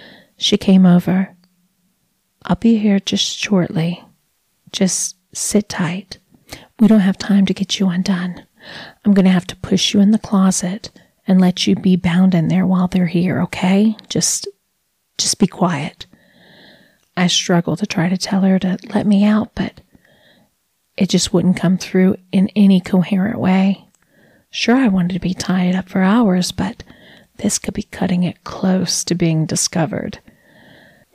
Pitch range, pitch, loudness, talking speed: 180-200 Hz, 190 Hz, -16 LUFS, 160 wpm